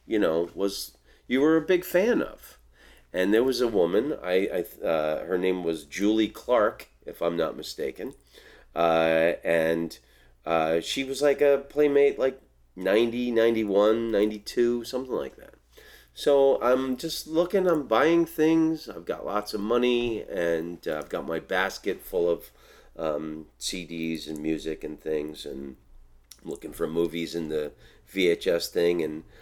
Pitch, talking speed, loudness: 105 Hz, 155 wpm, -26 LUFS